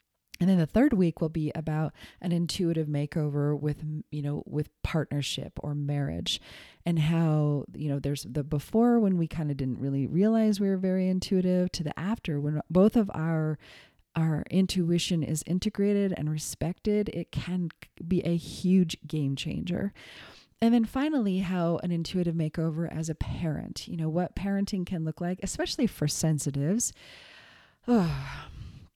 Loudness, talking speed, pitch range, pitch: -29 LUFS, 160 wpm, 150-185 Hz, 165 Hz